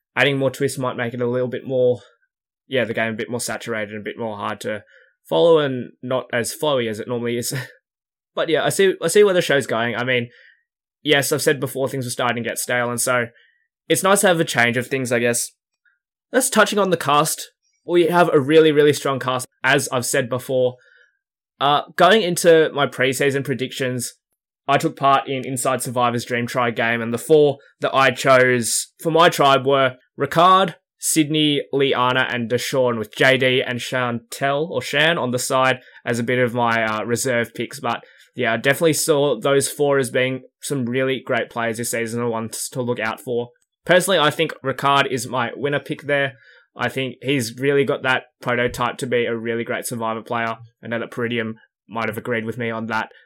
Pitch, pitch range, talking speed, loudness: 130 Hz, 120-140 Hz, 205 wpm, -19 LUFS